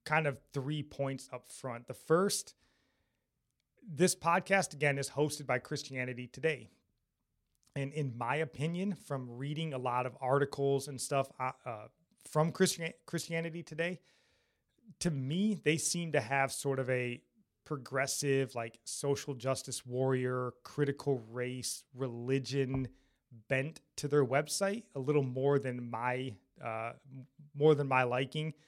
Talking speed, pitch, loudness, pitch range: 130 wpm, 140 Hz, -35 LUFS, 130-155 Hz